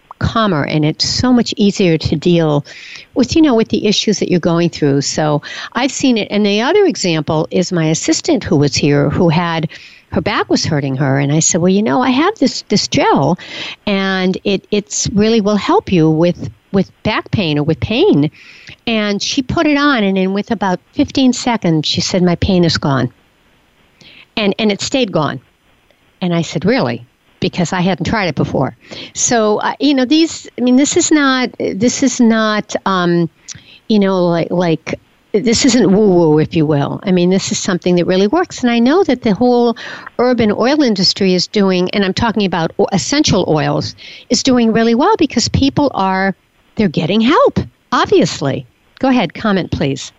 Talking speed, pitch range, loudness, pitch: 190 wpm, 165-235 Hz, -14 LUFS, 195 Hz